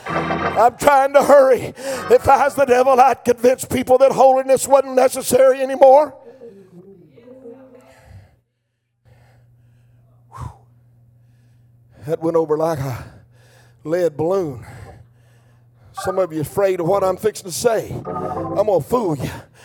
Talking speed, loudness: 120 wpm, -16 LUFS